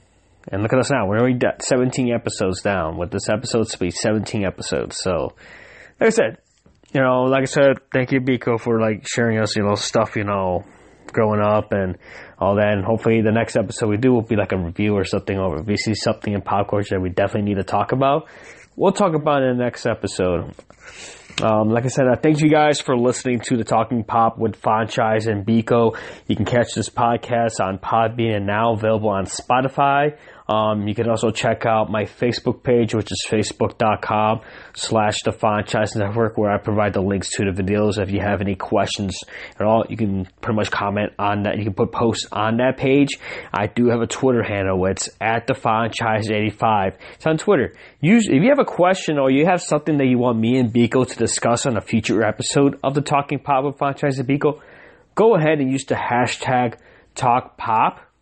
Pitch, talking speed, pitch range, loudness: 115 Hz, 210 wpm, 105-130 Hz, -19 LUFS